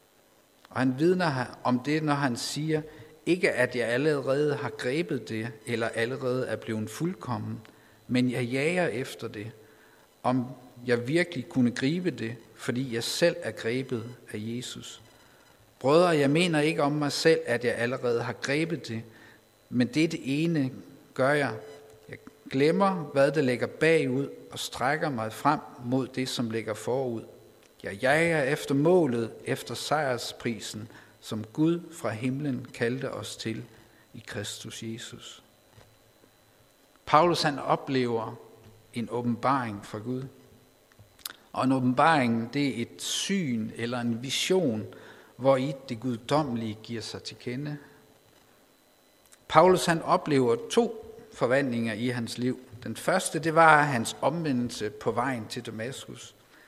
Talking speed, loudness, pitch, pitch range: 140 wpm, -28 LUFS, 125 Hz, 115-145 Hz